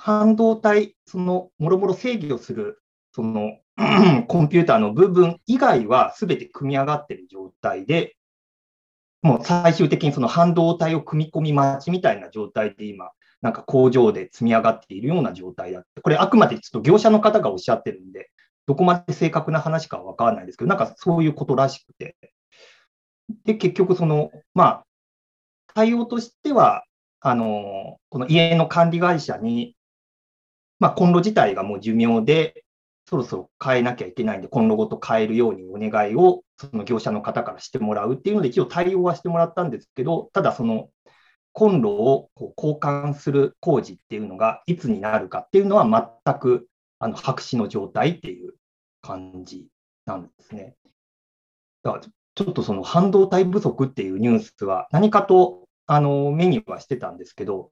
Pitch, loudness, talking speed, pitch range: 170 Hz, -20 LUFS, 355 characters per minute, 130-205 Hz